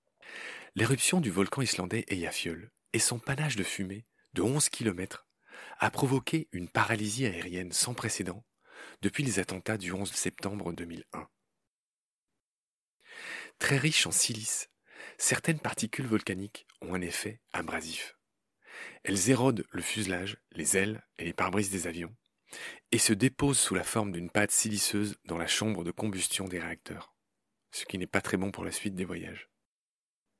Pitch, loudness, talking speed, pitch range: 105 Hz, -30 LUFS, 150 wpm, 95-115 Hz